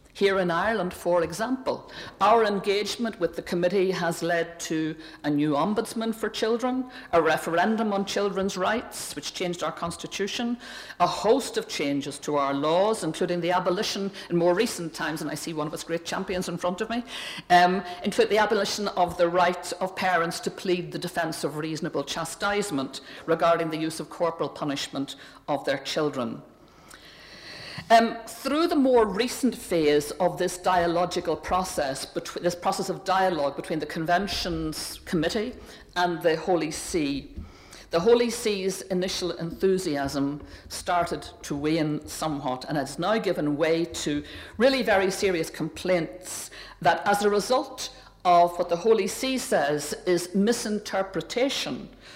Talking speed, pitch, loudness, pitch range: 150 wpm, 180 Hz, -26 LUFS, 165-205 Hz